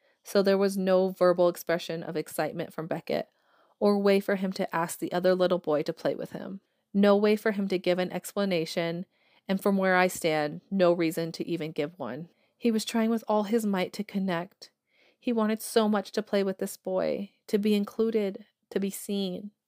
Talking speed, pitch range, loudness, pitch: 205 wpm, 175-205 Hz, -28 LUFS, 195 Hz